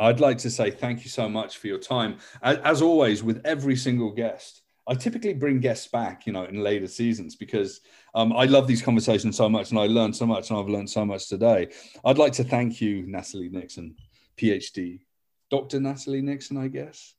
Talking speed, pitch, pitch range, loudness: 205 wpm, 115 Hz, 105-135 Hz, -25 LUFS